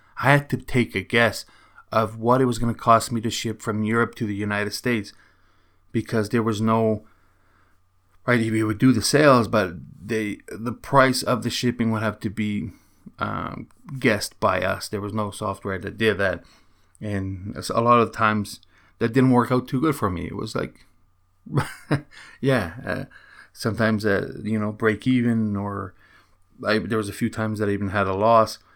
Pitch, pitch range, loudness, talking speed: 110 Hz, 100-115 Hz, -23 LUFS, 190 wpm